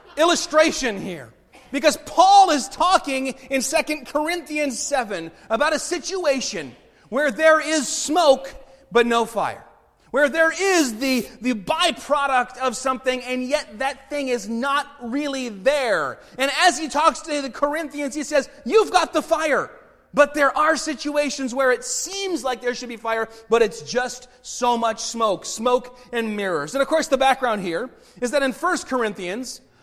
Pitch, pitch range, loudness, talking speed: 270 Hz, 245-305 Hz, -21 LUFS, 165 wpm